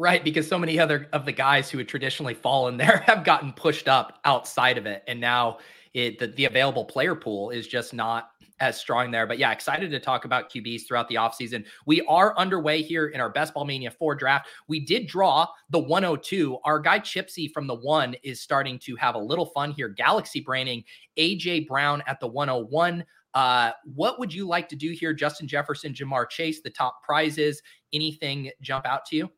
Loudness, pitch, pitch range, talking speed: -25 LUFS, 145 Hz, 125-155 Hz, 205 wpm